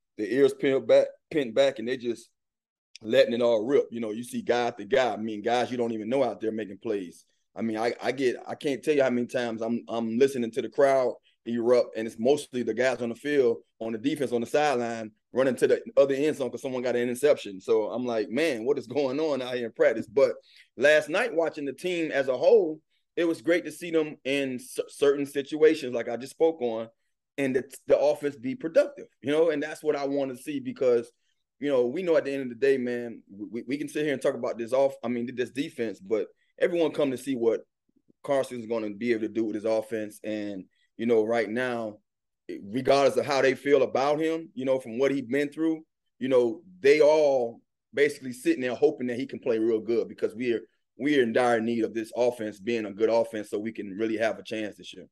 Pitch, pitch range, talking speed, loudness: 135 Hz, 115-160 Hz, 245 wpm, -27 LUFS